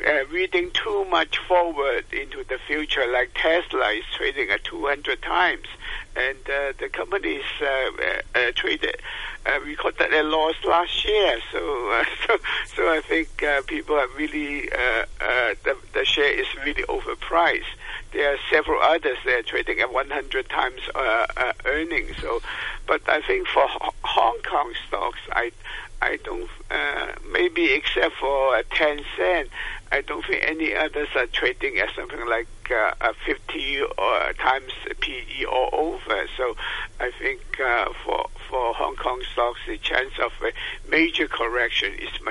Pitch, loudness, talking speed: 395 Hz, -23 LUFS, 165 wpm